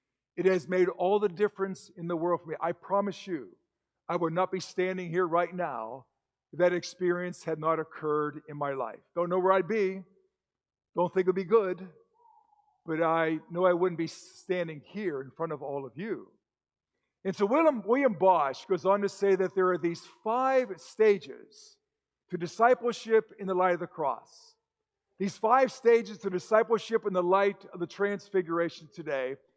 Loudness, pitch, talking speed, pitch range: -29 LUFS, 185 Hz, 185 wpm, 170-220 Hz